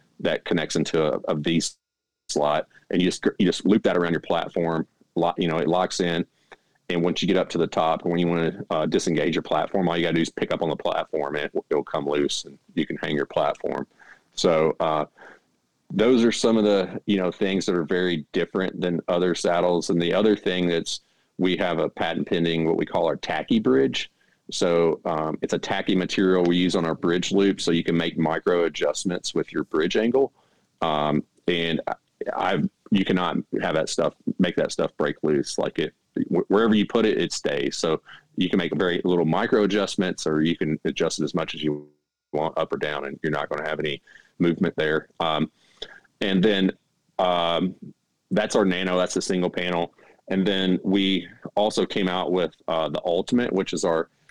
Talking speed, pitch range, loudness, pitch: 210 wpm, 80-95 Hz, -24 LUFS, 85 Hz